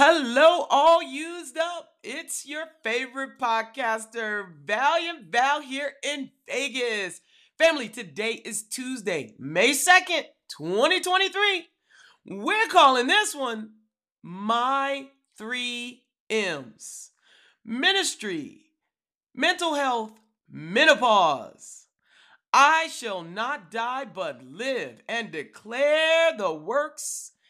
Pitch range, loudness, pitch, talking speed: 230-320 Hz, -24 LUFS, 275 Hz, 90 wpm